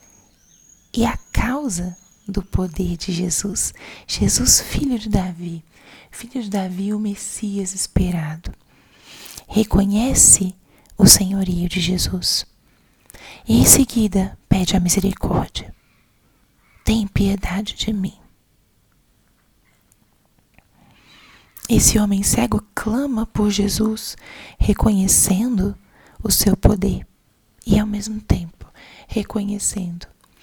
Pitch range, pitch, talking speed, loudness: 185-215 Hz, 195 Hz, 95 wpm, -18 LUFS